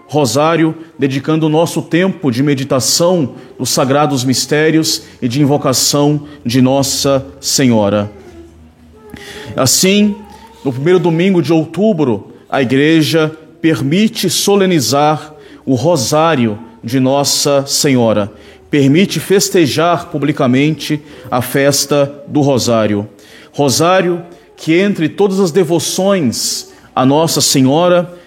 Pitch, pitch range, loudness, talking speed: 150 Hz, 135-170 Hz, -12 LUFS, 100 wpm